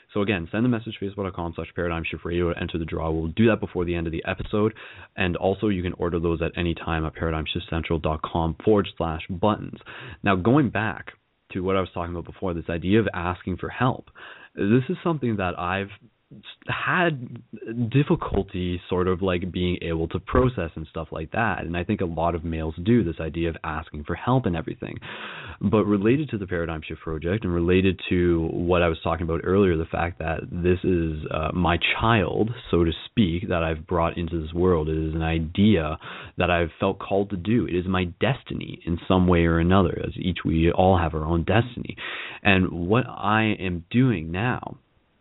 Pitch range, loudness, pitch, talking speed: 85-105 Hz, -24 LUFS, 90 Hz, 205 wpm